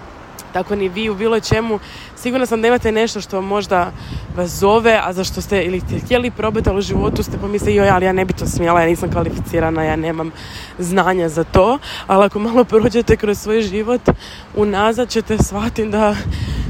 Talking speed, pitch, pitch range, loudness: 190 wpm, 205 Hz, 185-225 Hz, -17 LUFS